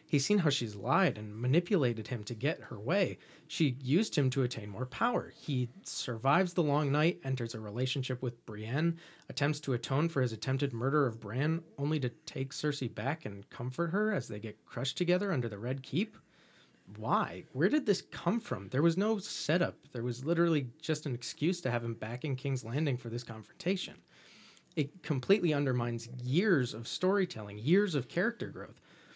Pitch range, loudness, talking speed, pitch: 120-165 Hz, -33 LUFS, 185 wpm, 140 Hz